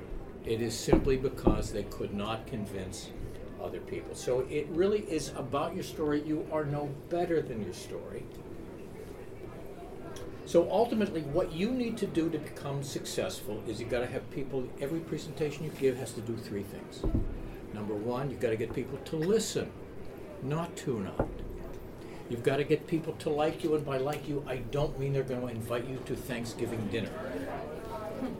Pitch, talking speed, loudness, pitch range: 140 Hz, 180 wpm, -34 LUFS, 120-160 Hz